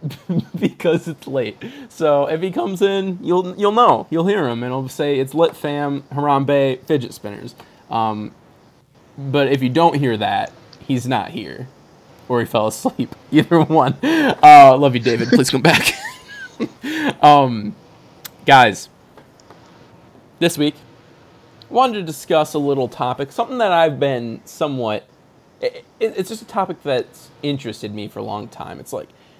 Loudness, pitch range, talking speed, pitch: -16 LUFS, 130-190 Hz, 155 wpm, 150 Hz